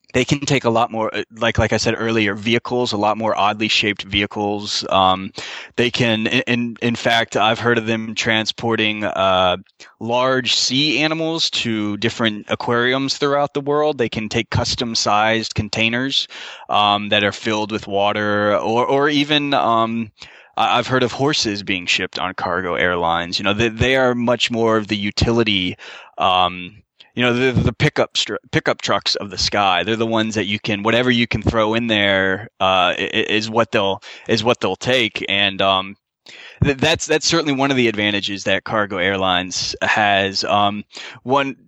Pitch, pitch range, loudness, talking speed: 110 Hz, 105-120 Hz, -18 LUFS, 175 wpm